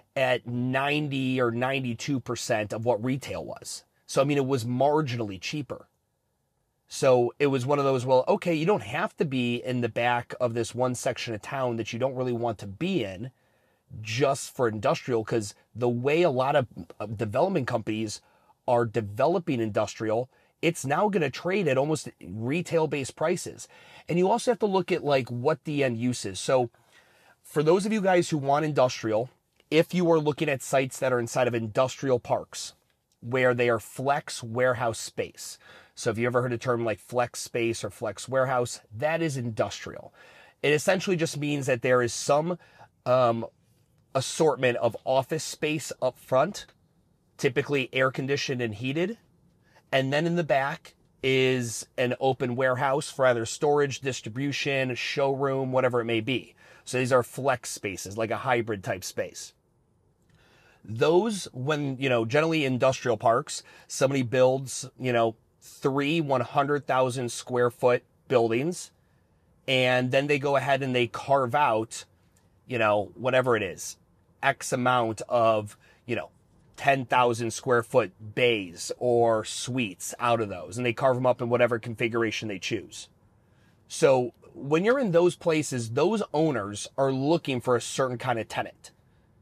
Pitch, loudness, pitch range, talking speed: 130 Hz, -27 LUFS, 120-140 Hz, 160 wpm